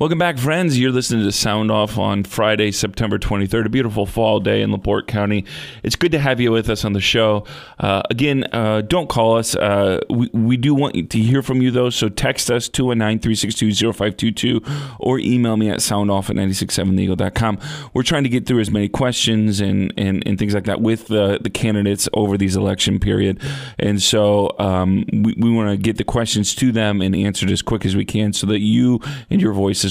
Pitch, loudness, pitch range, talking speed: 110 Hz, -18 LUFS, 100-125 Hz, 205 wpm